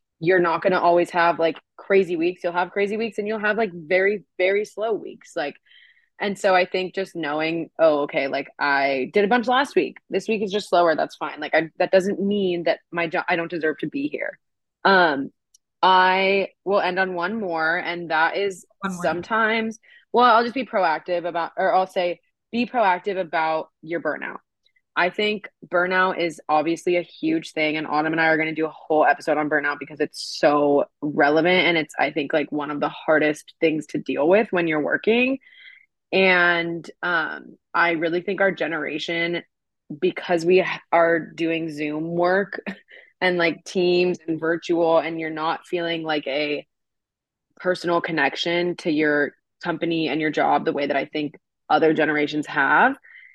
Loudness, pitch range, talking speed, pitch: -22 LUFS, 160-190 Hz, 185 wpm, 170 Hz